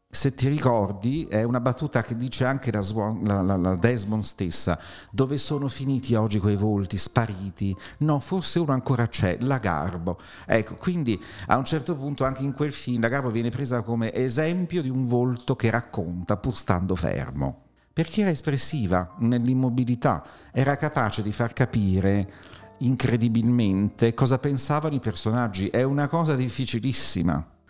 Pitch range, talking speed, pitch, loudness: 105-135 Hz, 155 wpm, 120 Hz, -25 LUFS